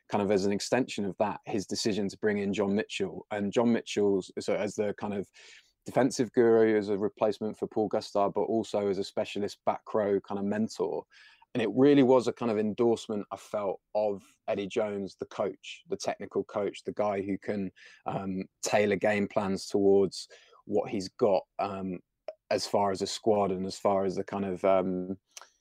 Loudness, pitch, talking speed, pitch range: -30 LUFS, 100 Hz, 195 wpm, 95-110 Hz